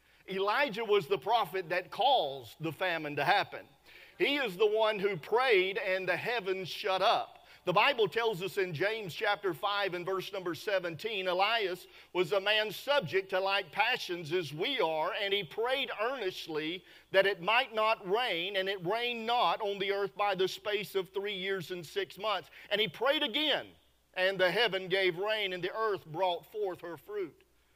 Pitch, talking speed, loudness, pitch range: 195 Hz, 185 wpm, -31 LUFS, 185-215 Hz